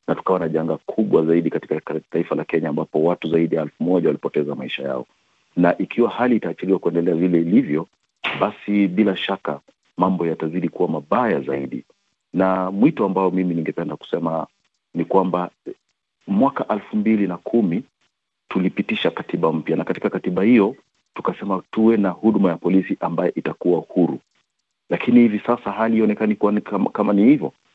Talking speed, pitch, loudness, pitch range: 150 wpm, 95 Hz, -20 LUFS, 85-105 Hz